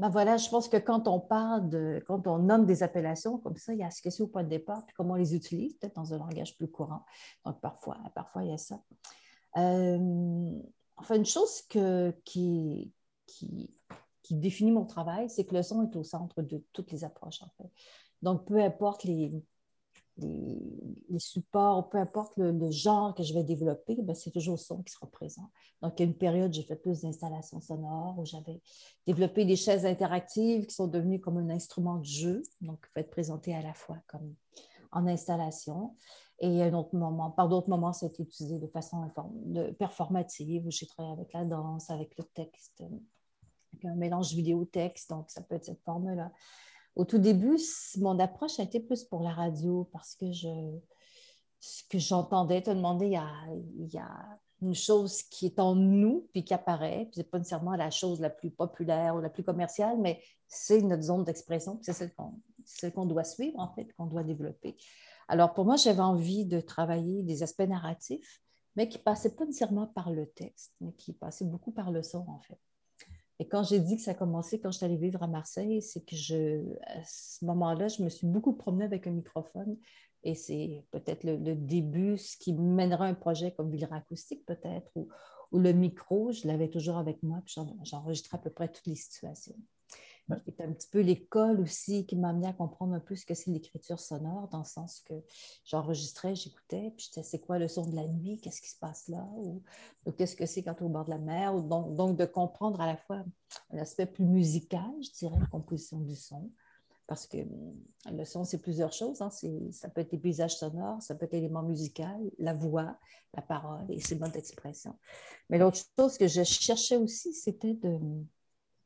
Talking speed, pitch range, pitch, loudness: 210 wpm, 165-200 Hz, 175 Hz, -32 LUFS